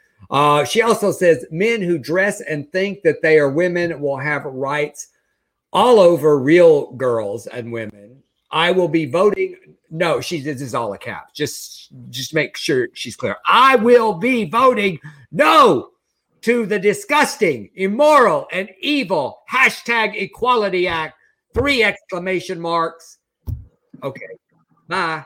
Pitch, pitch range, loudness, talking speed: 185 Hz, 155-235 Hz, -17 LUFS, 140 wpm